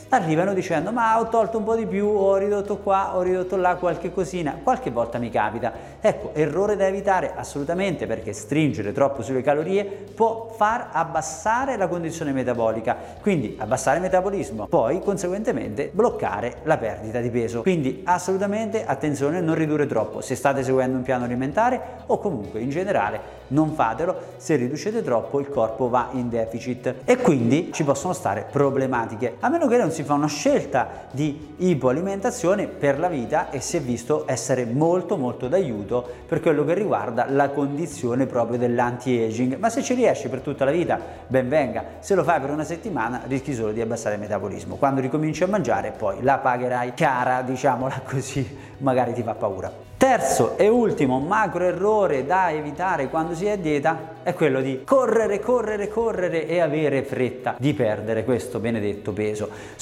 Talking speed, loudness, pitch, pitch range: 170 wpm, -23 LUFS, 145 Hz, 125-185 Hz